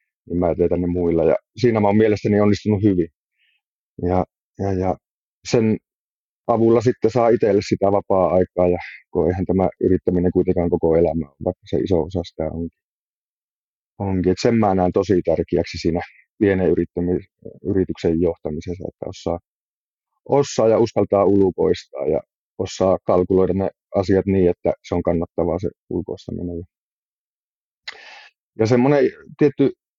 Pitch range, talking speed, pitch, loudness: 90-110 Hz, 140 wpm, 95 Hz, -20 LUFS